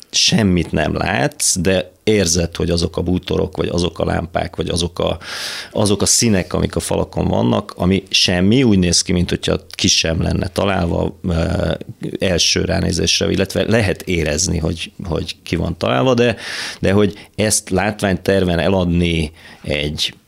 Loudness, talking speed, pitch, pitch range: -17 LUFS, 150 wpm, 95 Hz, 85-95 Hz